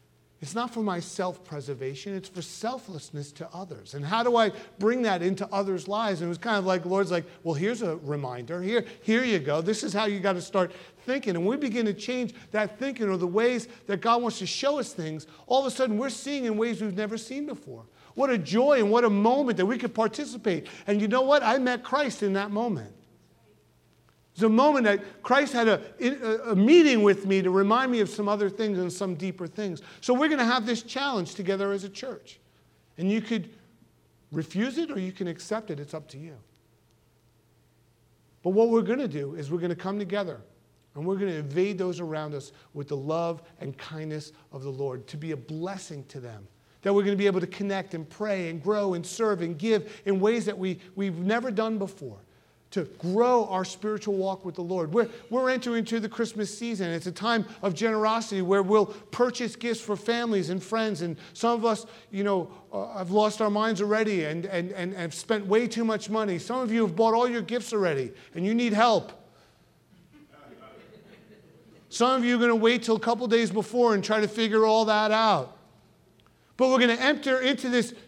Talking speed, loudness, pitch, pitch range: 220 wpm, -27 LUFS, 205 Hz, 175-230 Hz